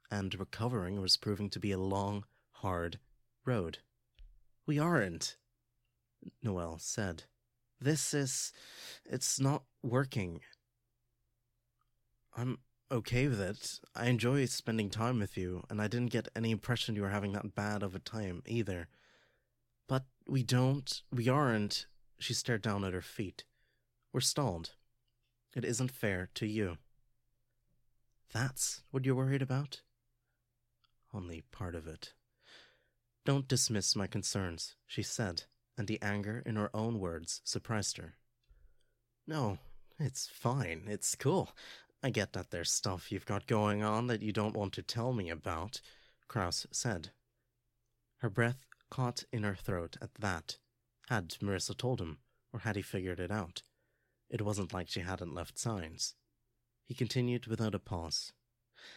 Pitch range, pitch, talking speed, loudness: 100-120 Hz, 115 Hz, 140 wpm, -36 LUFS